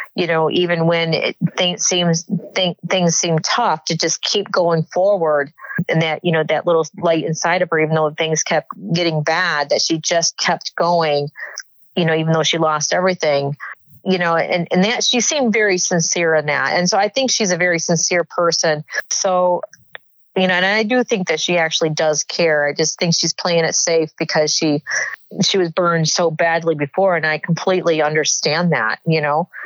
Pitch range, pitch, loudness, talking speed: 155-180 Hz, 170 Hz, -17 LUFS, 200 wpm